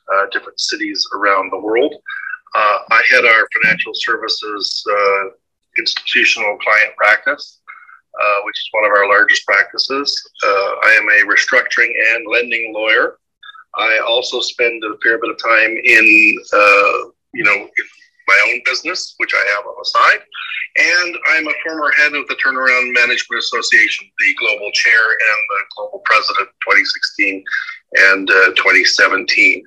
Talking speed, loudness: 150 wpm, -12 LUFS